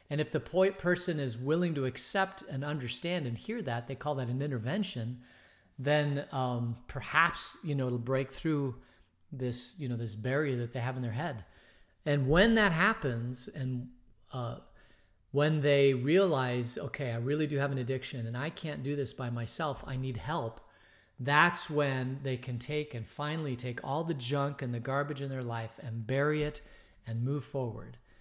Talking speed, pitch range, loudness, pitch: 185 wpm, 120-150 Hz, -32 LUFS, 135 Hz